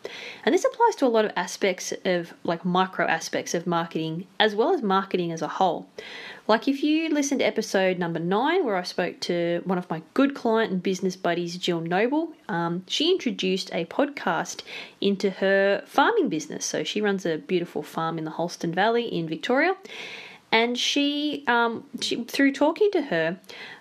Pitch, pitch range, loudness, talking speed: 195 Hz, 175-250 Hz, -25 LUFS, 180 wpm